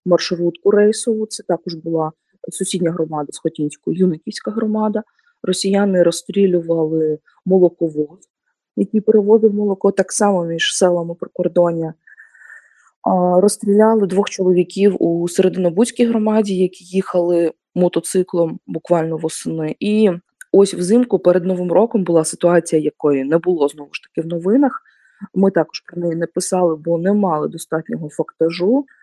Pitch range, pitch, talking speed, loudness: 165-205 Hz, 180 Hz, 120 wpm, -17 LUFS